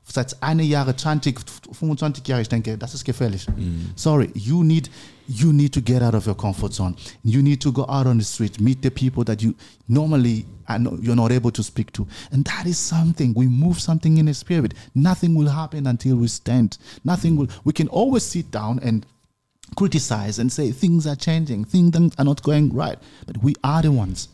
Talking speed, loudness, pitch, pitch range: 185 wpm, -20 LUFS, 130 Hz, 115-155 Hz